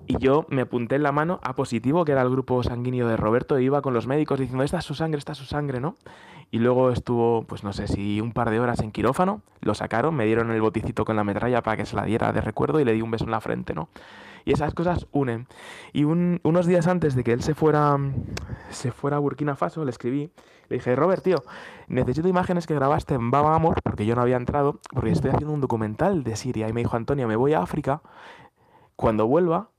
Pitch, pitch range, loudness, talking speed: 130 Hz, 115-150 Hz, -24 LUFS, 250 wpm